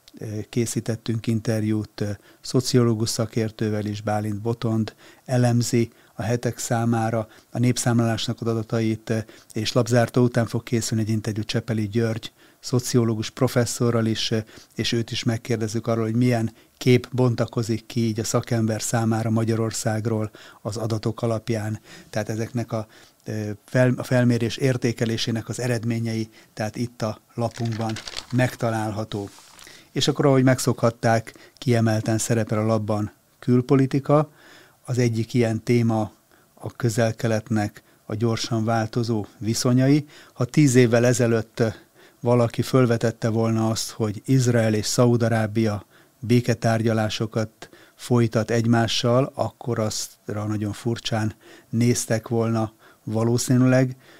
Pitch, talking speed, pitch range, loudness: 115 Hz, 110 wpm, 110-120 Hz, -23 LUFS